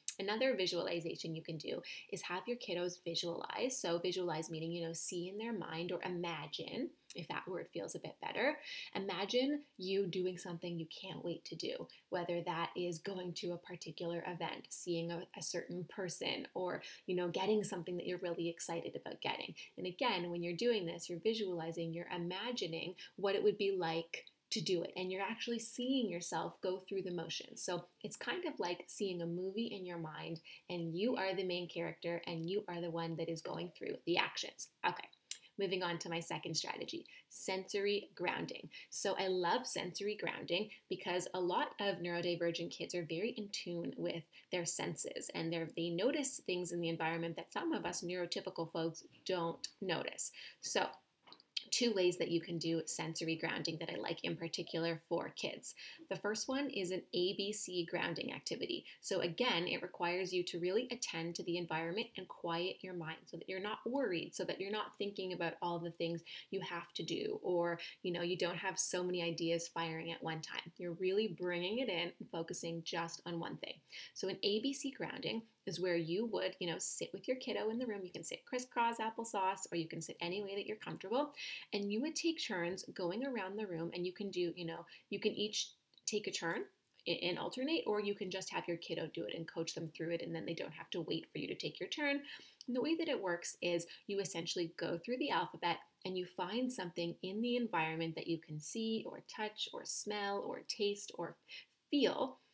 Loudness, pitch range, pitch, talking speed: -38 LUFS, 170-205 Hz, 180 Hz, 205 wpm